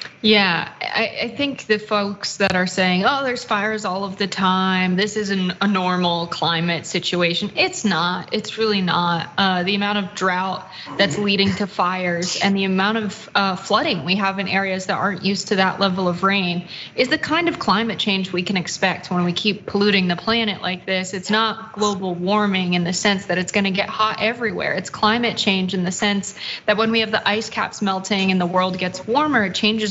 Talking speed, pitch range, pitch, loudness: 210 wpm, 185-210 Hz, 195 Hz, -20 LUFS